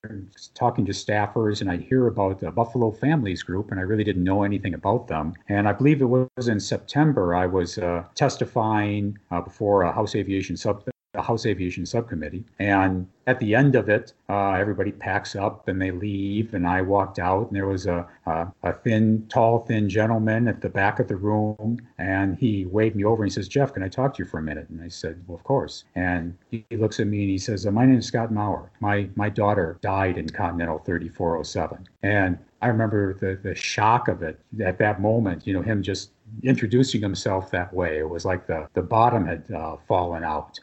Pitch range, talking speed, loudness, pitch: 95-110 Hz, 215 wpm, -24 LUFS, 100 Hz